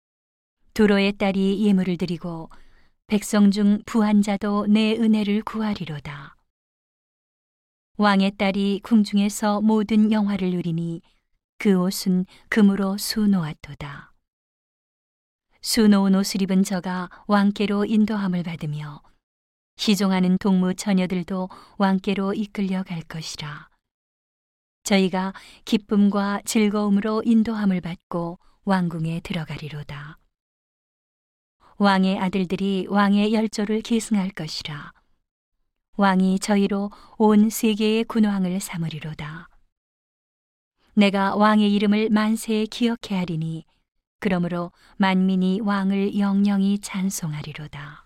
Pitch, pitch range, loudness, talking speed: 195 Hz, 180-210 Hz, -22 LUFS, 235 characters per minute